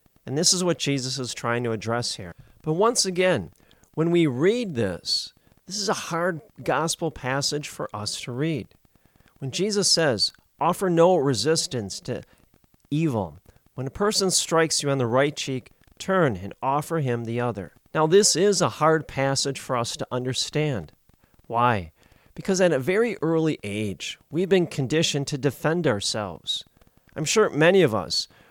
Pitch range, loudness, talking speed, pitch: 120-165 Hz, -24 LUFS, 165 wpm, 145 Hz